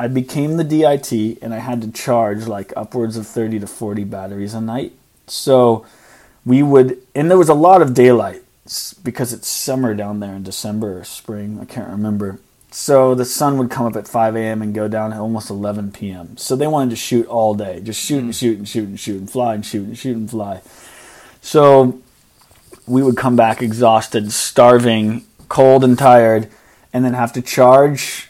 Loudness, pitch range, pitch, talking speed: -15 LUFS, 110-130 Hz, 115 Hz, 195 wpm